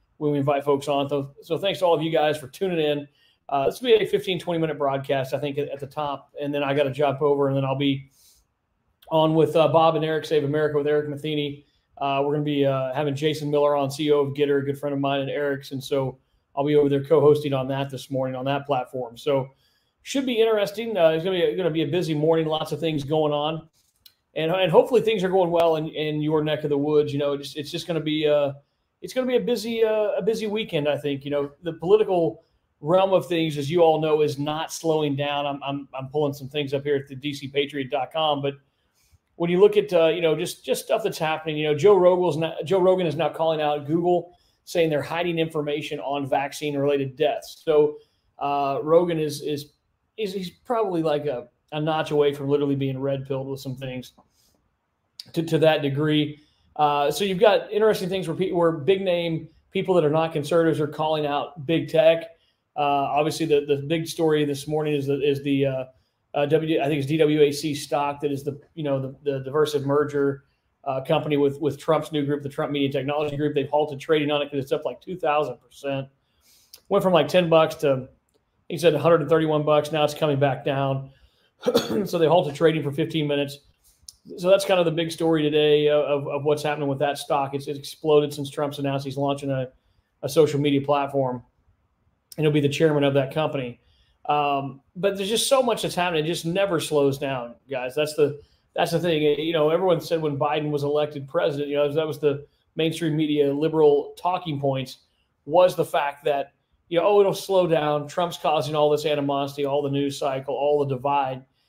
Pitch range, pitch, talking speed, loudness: 140-160 Hz, 150 Hz, 220 wpm, -23 LUFS